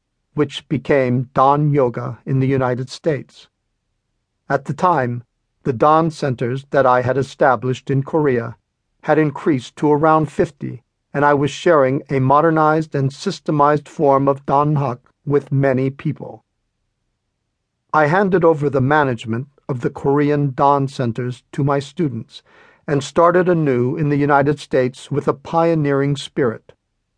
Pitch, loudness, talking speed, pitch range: 140 Hz, -17 LUFS, 140 wpm, 130-150 Hz